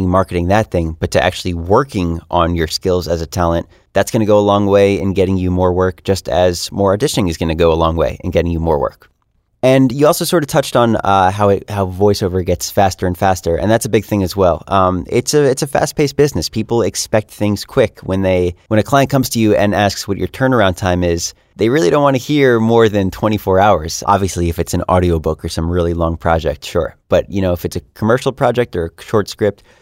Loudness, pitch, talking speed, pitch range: -15 LUFS, 95 Hz, 250 wpm, 90-110 Hz